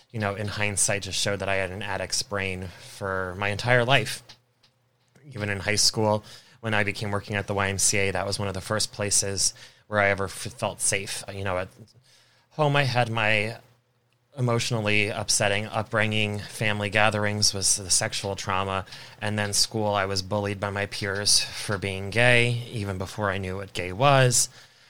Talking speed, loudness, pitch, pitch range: 180 wpm, -24 LUFS, 105 Hz, 100-120 Hz